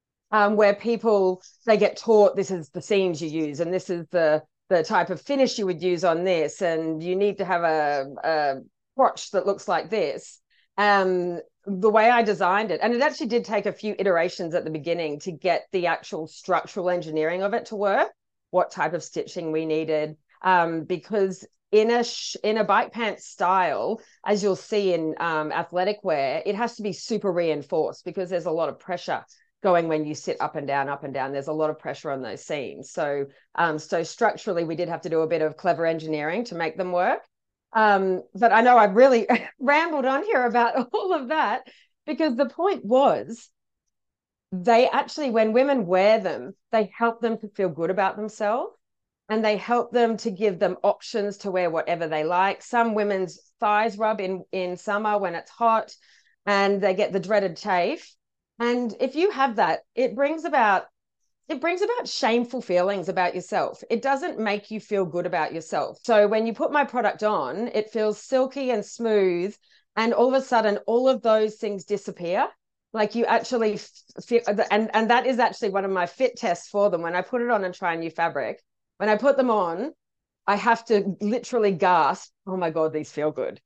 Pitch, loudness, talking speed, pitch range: 205 Hz, -24 LUFS, 200 wpm, 175-230 Hz